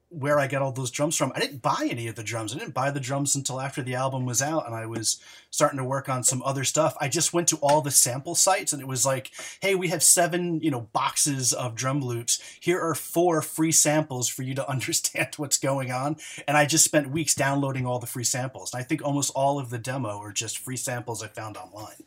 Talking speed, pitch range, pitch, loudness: 255 wpm, 125-155 Hz, 140 Hz, -24 LUFS